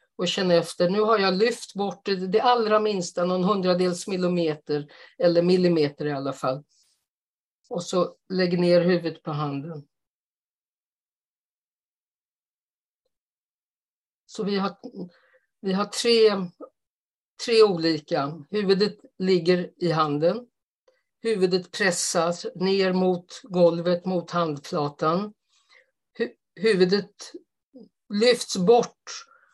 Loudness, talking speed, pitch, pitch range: -24 LUFS, 100 wpm, 185 Hz, 170-220 Hz